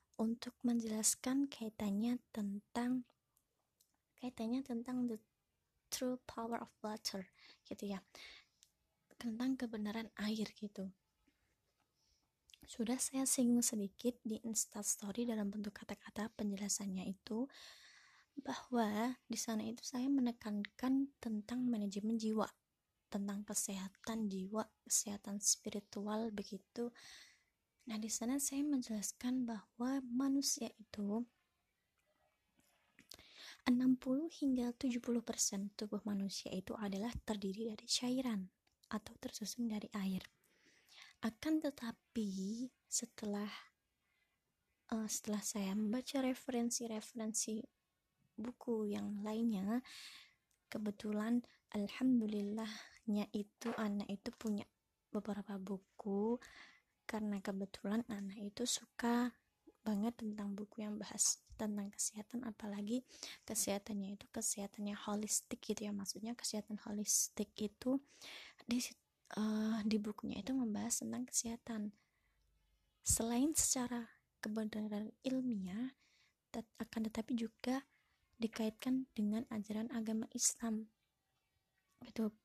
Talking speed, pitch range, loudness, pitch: 95 wpm, 210-245 Hz, -41 LUFS, 225 Hz